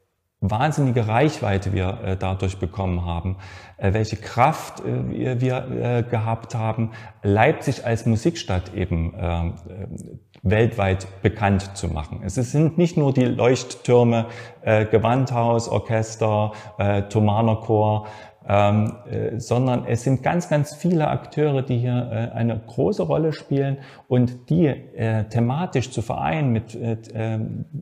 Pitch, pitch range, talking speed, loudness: 115 Hz, 100-130 Hz, 105 wpm, -22 LUFS